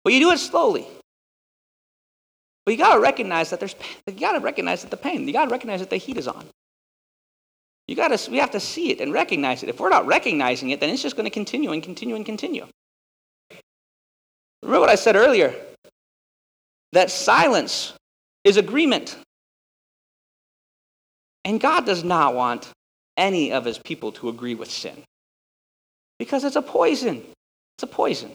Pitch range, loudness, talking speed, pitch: 180-300 Hz, -21 LUFS, 165 wpm, 220 Hz